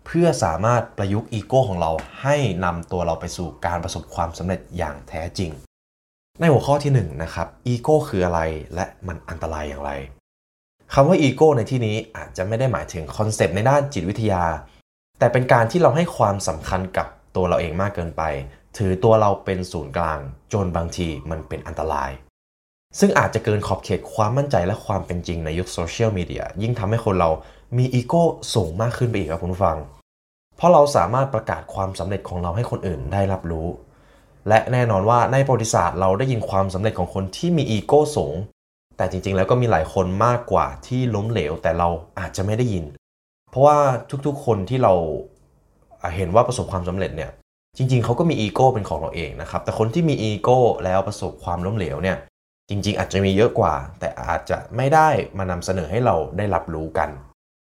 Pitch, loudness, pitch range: 95 Hz, -21 LUFS, 85-115 Hz